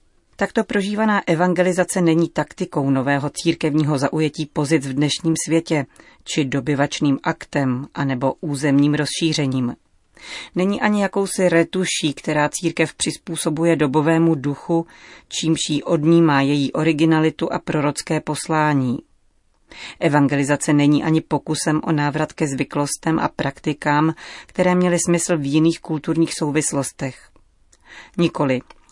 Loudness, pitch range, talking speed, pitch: -20 LUFS, 145-165 Hz, 110 wpm, 155 Hz